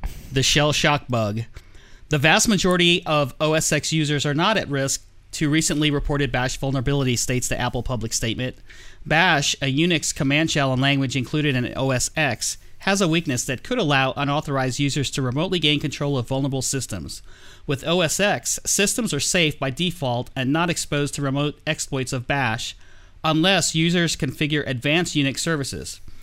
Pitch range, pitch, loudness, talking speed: 125-155 Hz, 140 Hz, -21 LUFS, 160 wpm